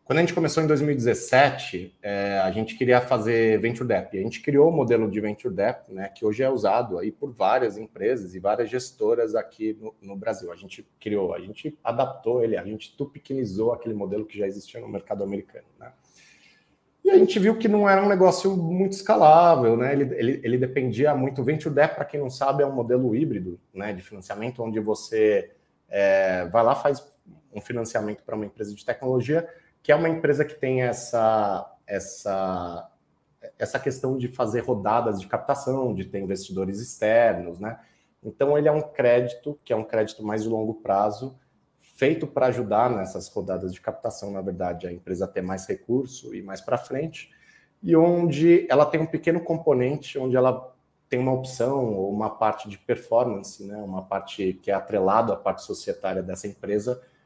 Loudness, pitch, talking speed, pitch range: -24 LUFS, 125 Hz, 190 wpm, 105-150 Hz